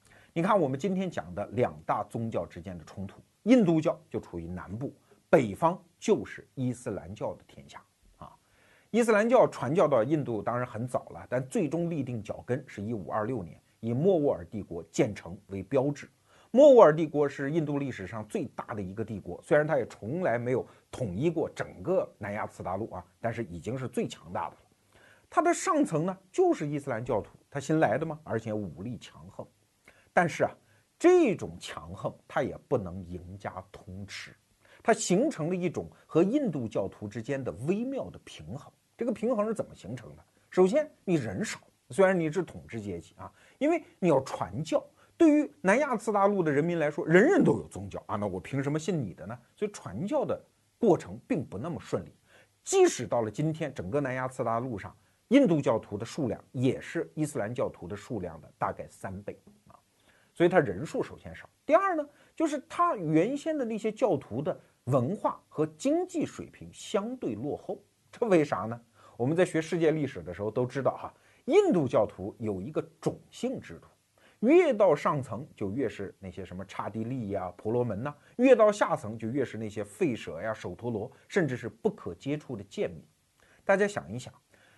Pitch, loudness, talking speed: 140 Hz, -29 LUFS, 285 characters per minute